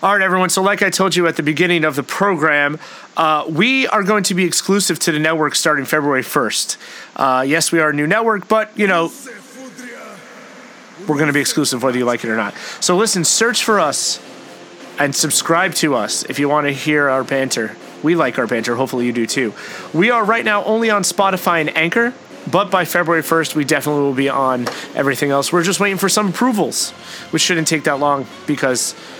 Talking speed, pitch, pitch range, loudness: 215 wpm, 160 Hz, 145-195 Hz, -16 LUFS